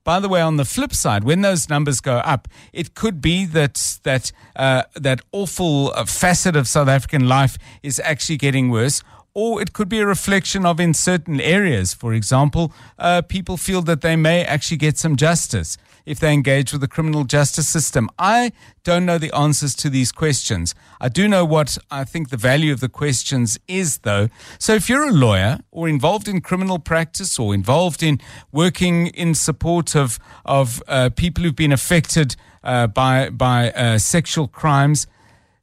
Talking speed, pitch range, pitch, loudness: 185 wpm, 130-170 Hz, 150 Hz, -18 LUFS